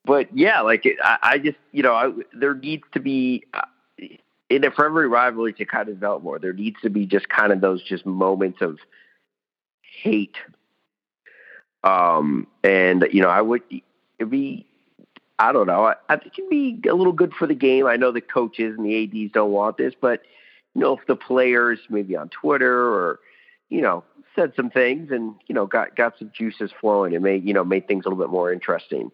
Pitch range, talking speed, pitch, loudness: 105-150 Hz, 210 wpm, 120 Hz, -20 LUFS